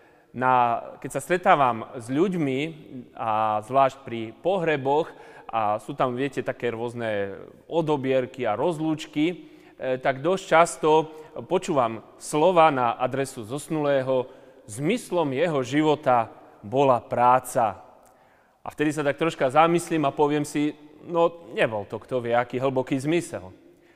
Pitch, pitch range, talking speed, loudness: 135 Hz, 125-155 Hz, 125 wpm, -24 LUFS